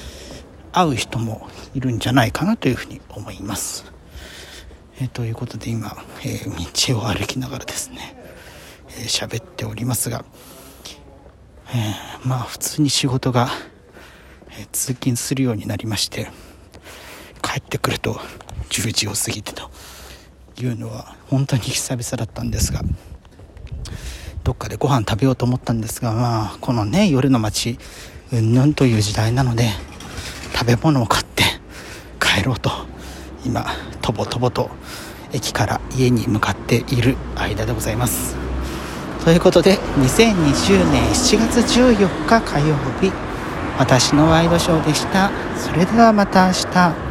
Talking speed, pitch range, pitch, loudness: 265 characters per minute, 95-135 Hz, 115 Hz, -19 LUFS